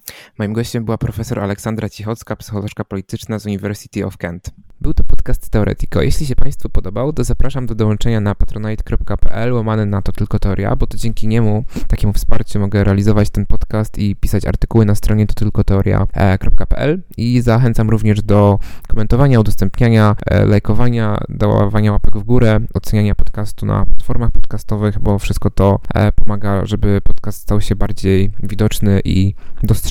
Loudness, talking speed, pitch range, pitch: -17 LUFS, 155 wpm, 100-115 Hz, 105 Hz